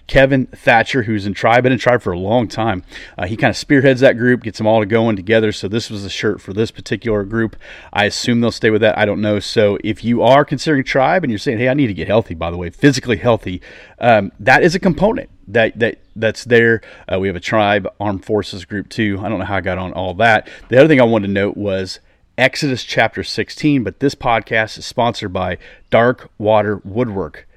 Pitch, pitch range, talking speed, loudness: 110 Hz, 100-125 Hz, 240 wpm, -16 LUFS